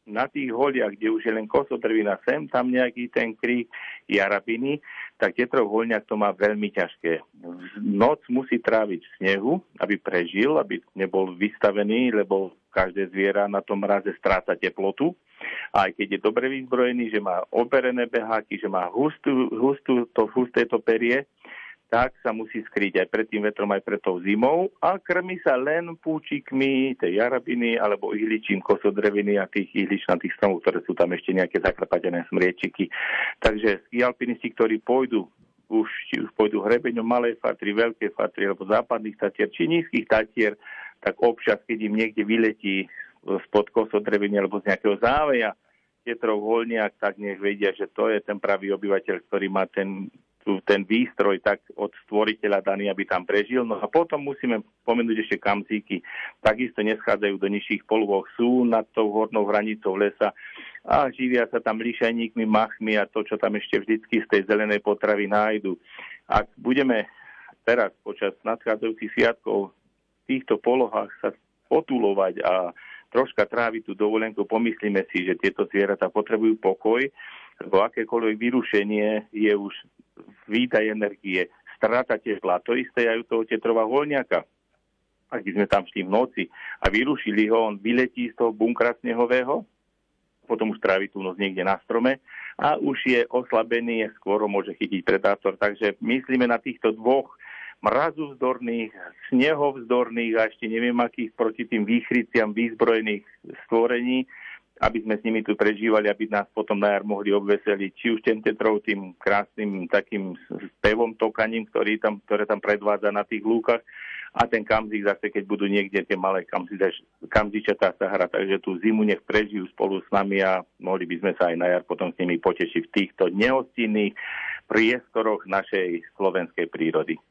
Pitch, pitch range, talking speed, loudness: 110 Hz, 100-120 Hz, 160 wpm, -24 LUFS